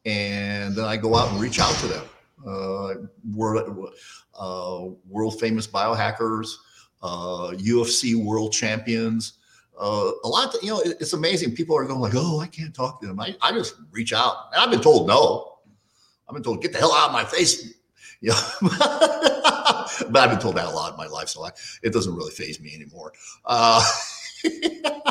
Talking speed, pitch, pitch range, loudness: 195 wpm, 115 Hz, 105-160 Hz, -22 LUFS